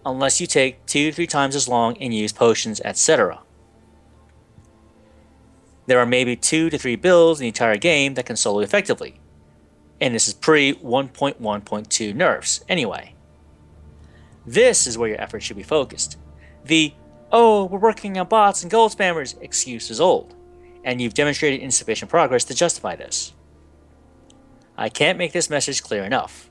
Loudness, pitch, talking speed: -19 LUFS, 120 Hz, 160 wpm